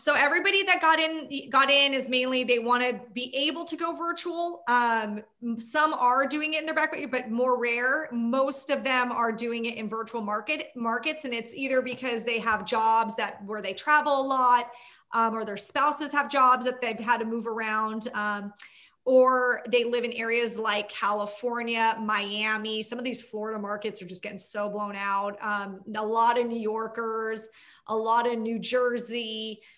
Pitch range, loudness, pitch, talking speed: 220-265 Hz, -26 LUFS, 235 Hz, 190 wpm